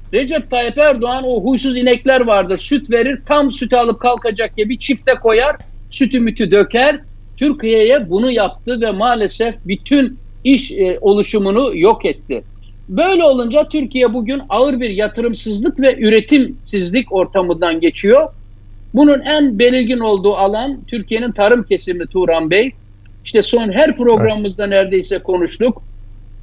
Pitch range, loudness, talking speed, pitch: 200-265 Hz, -14 LUFS, 130 wpm, 235 Hz